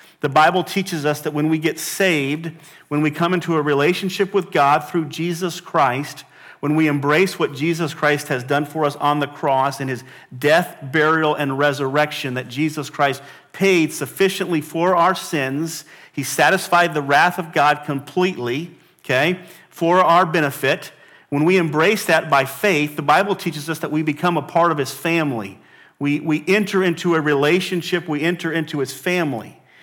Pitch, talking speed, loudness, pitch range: 155 Hz, 175 wpm, -19 LUFS, 145-175 Hz